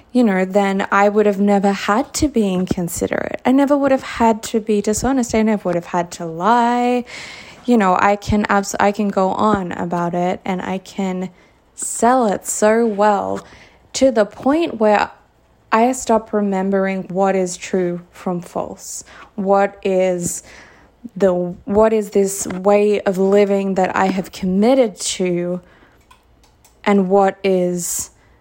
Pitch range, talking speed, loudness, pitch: 185-220 Hz, 155 wpm, -17 LUFS, 200 Hz